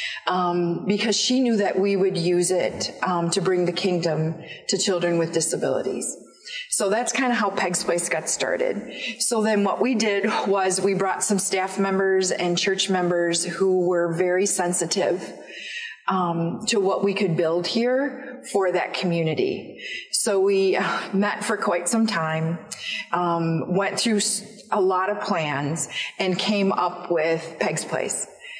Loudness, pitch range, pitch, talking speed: -23 LUFS, 175-205 Hz, 190 Hz, 155 wpm